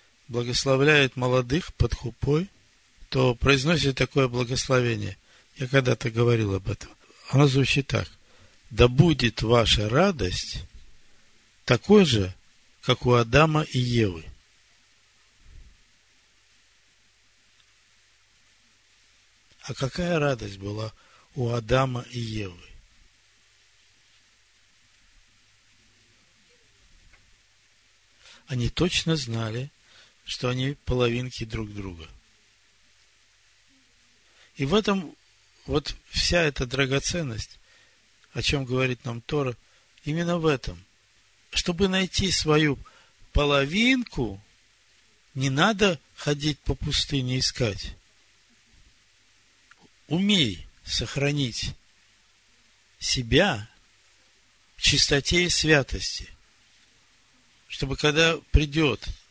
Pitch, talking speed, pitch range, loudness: 120 Hz, 80 wpm, 105-140 Hz, -24 LUFS